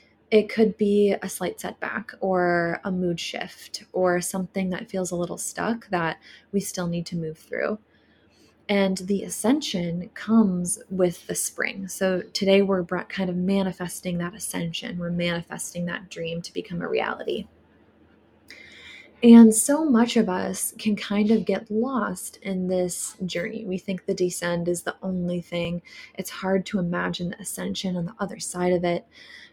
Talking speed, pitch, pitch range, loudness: 165 wpm, 190 Hz, 175-205 Hz, -24 LUFS